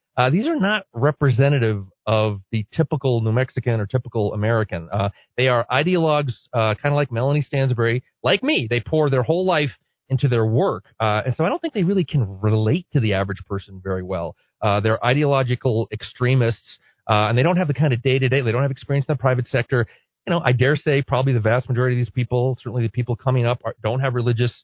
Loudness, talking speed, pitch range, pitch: -21 LUFS, 220 wpm, 110-140 Hz, 125 Hz